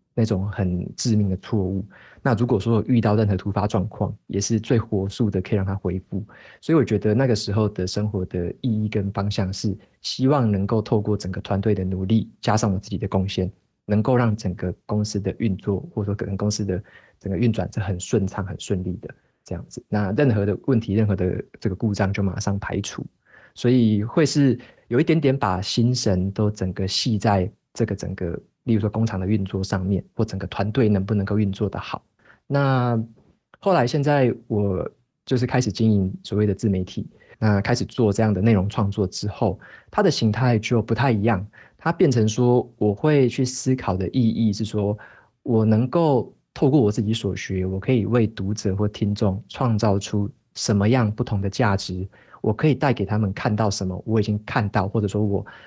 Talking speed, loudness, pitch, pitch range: 290 characters per minute, -22 LUFS, 105 Hz, 100-115 Hz